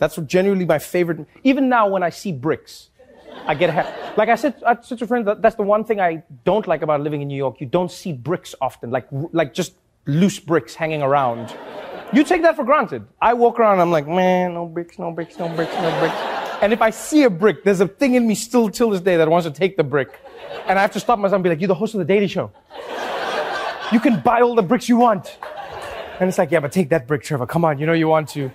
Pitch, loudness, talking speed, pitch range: 185 Hz, -19 LUFS, 260 wpm, 160-225 Hz